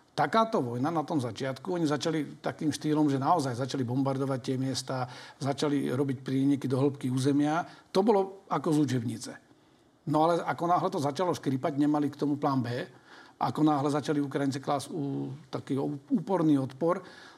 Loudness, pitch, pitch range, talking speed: -29 LUFS, 145 Hz, 135-155 Hz, 160 wpm